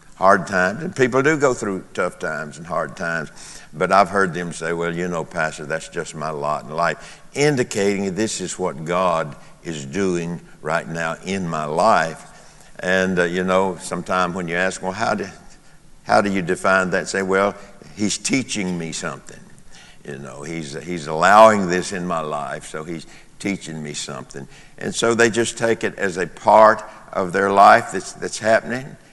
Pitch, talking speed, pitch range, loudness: 95 Hz, 185 wpm, 85-105 Hz, -20 LUFS